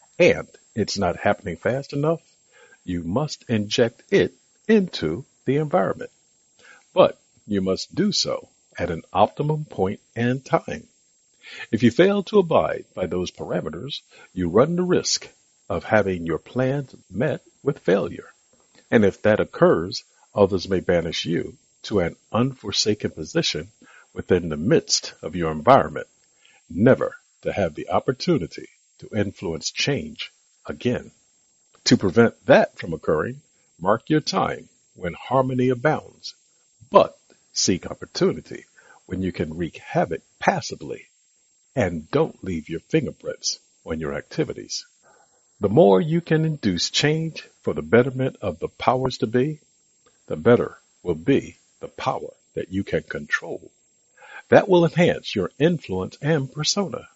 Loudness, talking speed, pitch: -22 LUFS, 135 wpm, 130 Hz